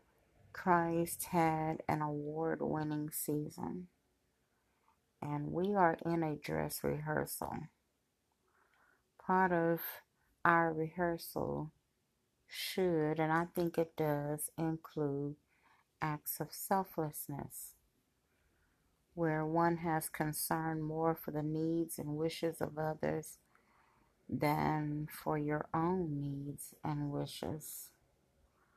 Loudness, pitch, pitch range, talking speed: -37 LUFS, 155 Hz, 145-165 Hz, 95 wpm